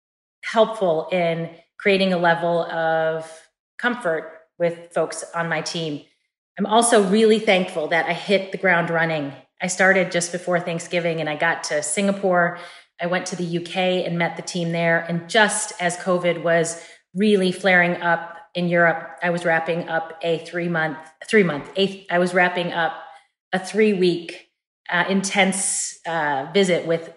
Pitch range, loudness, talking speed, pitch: 165-185 Hz, -21 LUFS, 155 wpm, 175 Hz